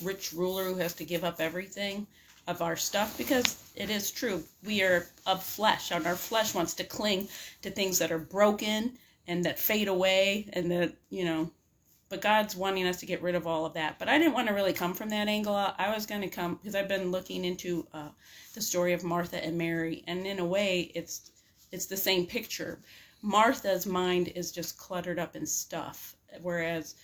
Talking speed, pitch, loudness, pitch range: 210 wpm, 185 Hz, -30 LUFS, 175-200 Hz